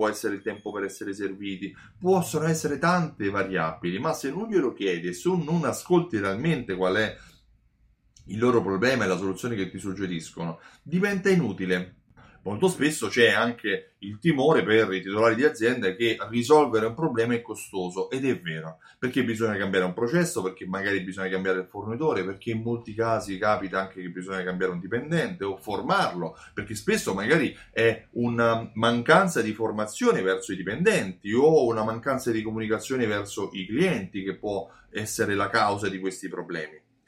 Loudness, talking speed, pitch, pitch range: -26 LUFS, 170 wpm, 110 Hz, 95-125 Hz